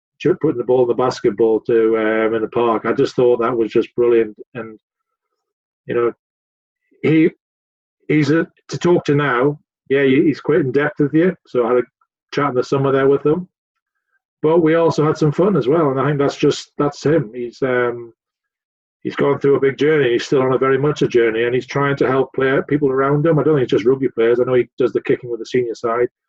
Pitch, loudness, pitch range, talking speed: 135 Hz, -17 LUFS, 120-150 Hz, 235 wpm